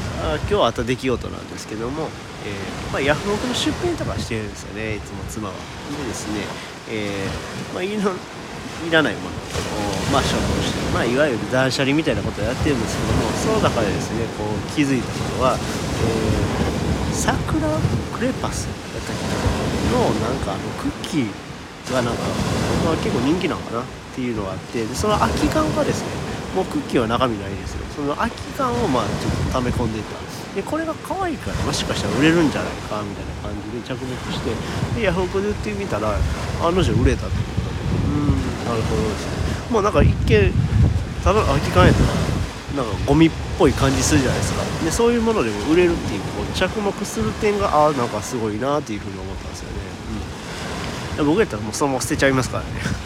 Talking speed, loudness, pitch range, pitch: 425 characters per minute, -21 LUFS, 100-145 Hz, 115 Hz